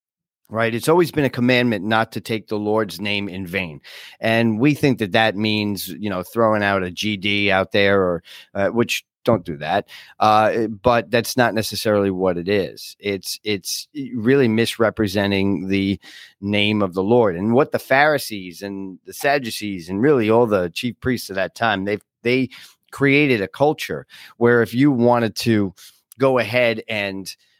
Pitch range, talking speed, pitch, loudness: 100-120 Hz, 175 wpm, 110 Hz, -19 LUFS